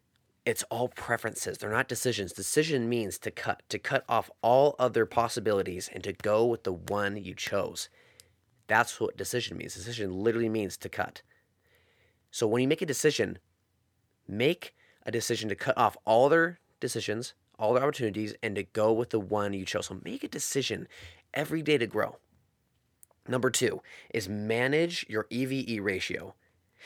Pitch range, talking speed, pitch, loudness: 105-125 Hz, 165 wpm, 115 Hz, -30 LUFS